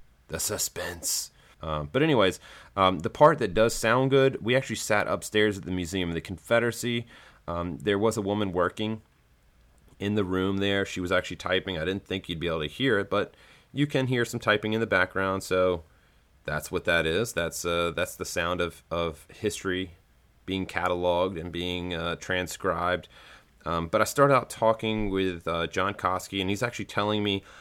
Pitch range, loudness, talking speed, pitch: 85-110 Hz, -27 LUFS, 190 wpm, 95 Hz